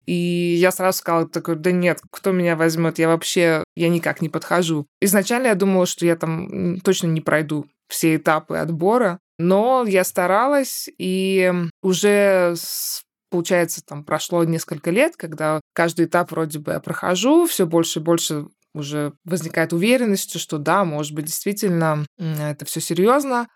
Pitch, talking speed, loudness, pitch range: 170 Hz, 155 wpm, -20 LUFS, 160-190 Hz